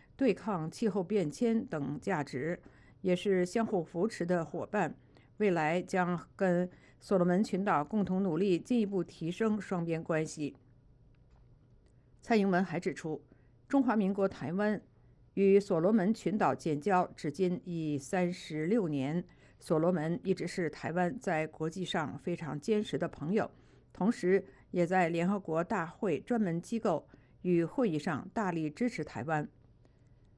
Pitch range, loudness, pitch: 155-195 Hz, -33 LUFS, 180 Hz